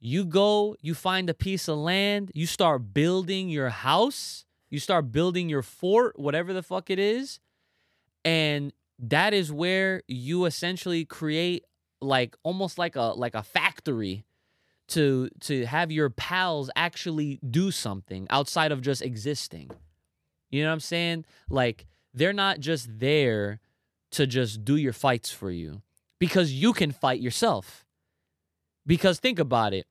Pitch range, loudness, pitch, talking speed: 115-175 Hz, -26 LUFS, 150 Hz, 150 wpm